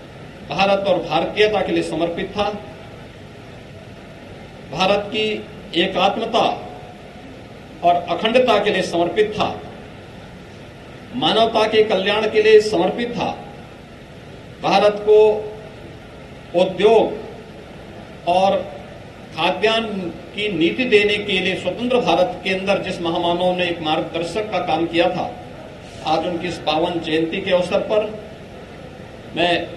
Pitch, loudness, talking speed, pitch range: 190 Hz, -18 LUFS, 110 wpm, 175-210 Hz